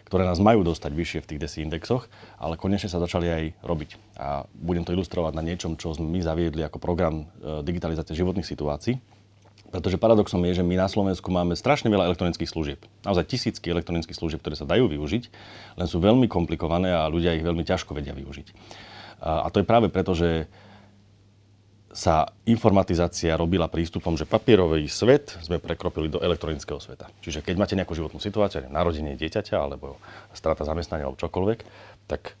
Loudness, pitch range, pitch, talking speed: -25 LUFS, 80-100 Hz, 90 Hz, 170 wpm